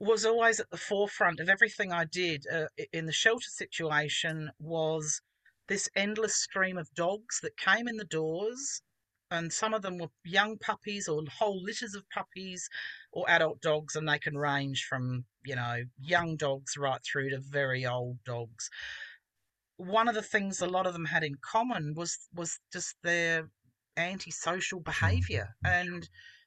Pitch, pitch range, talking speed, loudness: 170 Hz, 150-200 Hz, 170 wpm, -31 LUFS